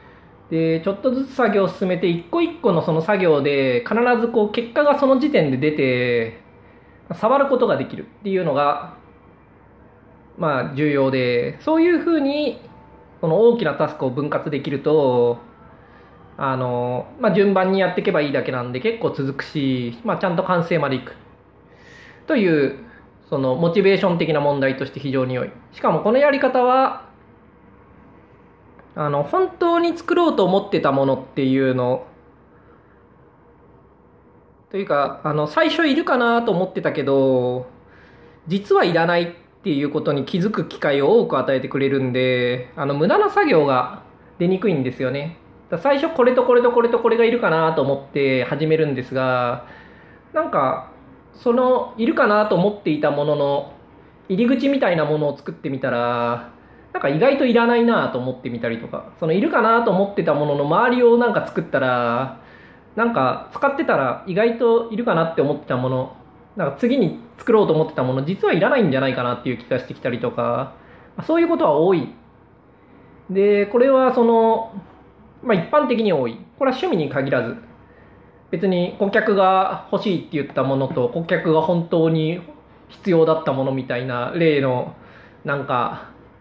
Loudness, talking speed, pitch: -19 LUFS, 325 characters per minute, 170 Hz